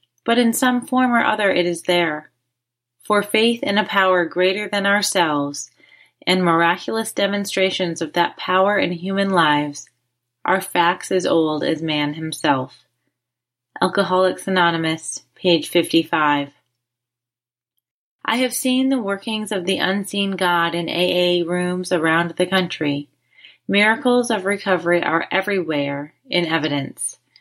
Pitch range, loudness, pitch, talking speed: 150-200 Hz, -19 LUFS, 175 Hz, 130 wpm